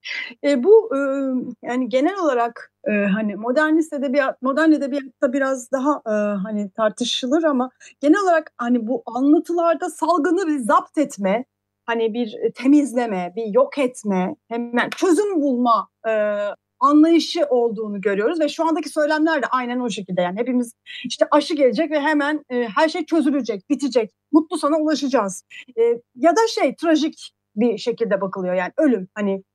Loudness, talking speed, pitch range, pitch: -20 LUFS, 155 wpm, 230-310 Hz, 270 Hz